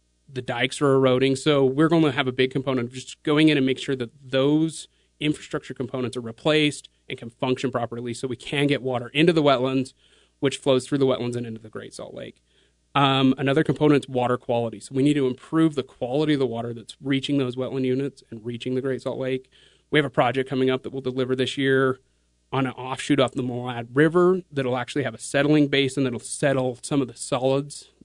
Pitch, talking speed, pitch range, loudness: 130 Hz, 225 wpm, 125-140 Hz, -23 LUFS